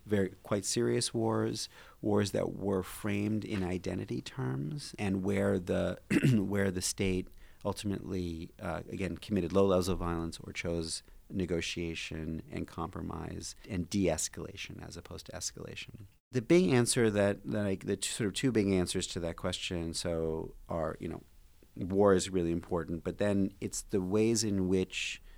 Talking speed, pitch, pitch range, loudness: 160 wpm, 95 Hz, 85-105 Hz, -33 LUFS